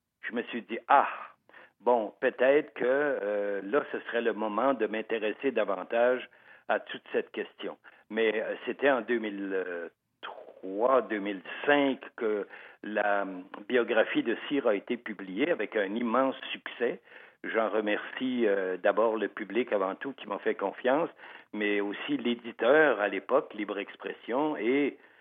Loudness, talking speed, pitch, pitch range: -30 LUFS, 145 wpm, 110 Hz, 105-140 Hz